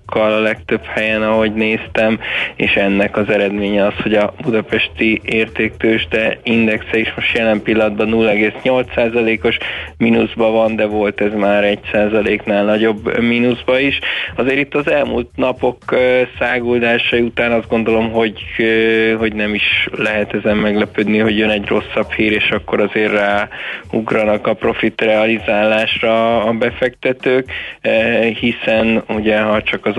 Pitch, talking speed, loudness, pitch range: 110 Hz, 130 wpm, -15 LUFS, 105-115 Hz